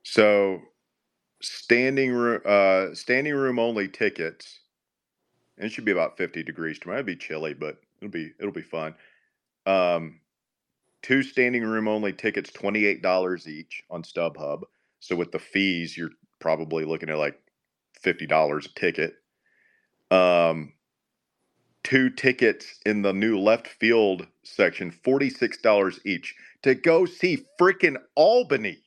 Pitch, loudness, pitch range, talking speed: 100 Hz, -24 LUFS, 85-125 Hz, 140 wpm